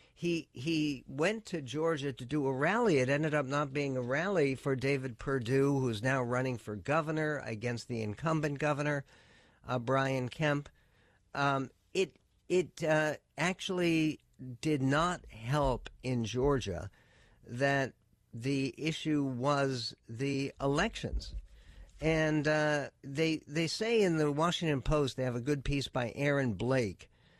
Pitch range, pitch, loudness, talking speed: 125-155 Hz, 140 Hz, -33 LUFS, 140 wpm